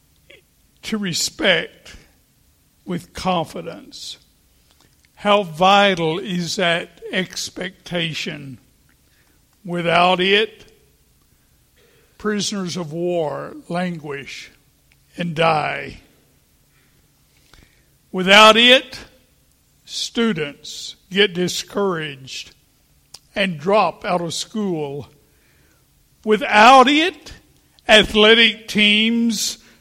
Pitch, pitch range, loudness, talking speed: 185 Hz, 160-215 Hz, -16 LUFS, 60 wpm